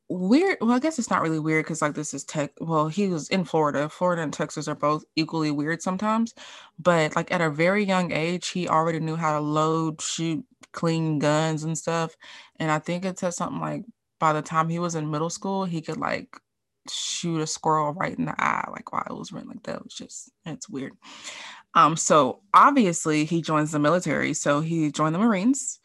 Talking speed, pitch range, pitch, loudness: 220 wpm, 155-185 Hz, 160 Hz, -24 LUFS